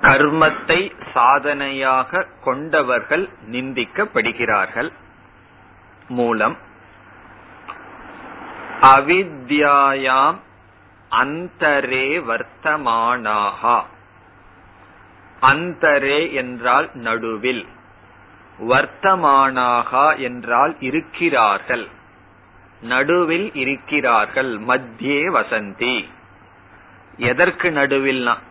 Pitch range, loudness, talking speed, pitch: 110-140 Hz, -17 LUFS, 35 wpm, 130 Hz